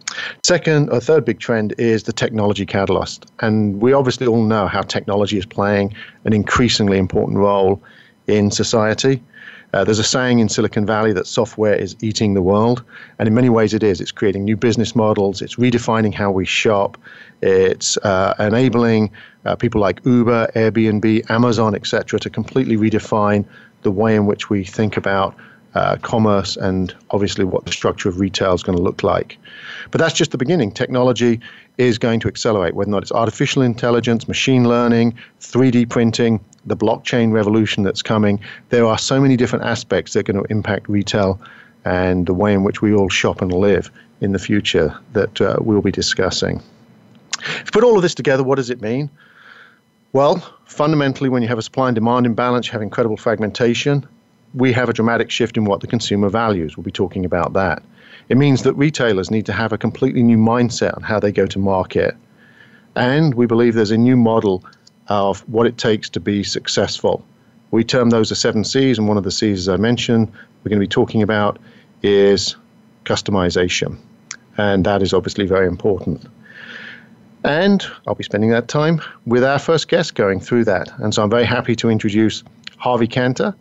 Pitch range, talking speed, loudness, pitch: 105-120 Hz, 190 wpm, -17 LUFS, 110 Hz